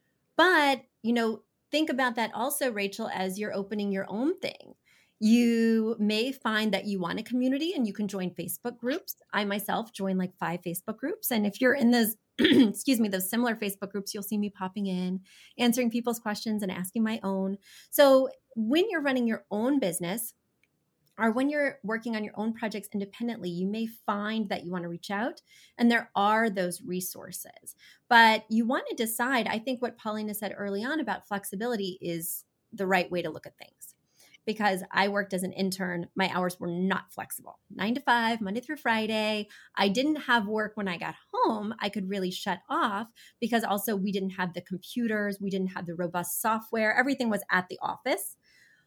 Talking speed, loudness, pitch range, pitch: 195 wpm, -28 LUFS, 195-235 Hz, 215 Hz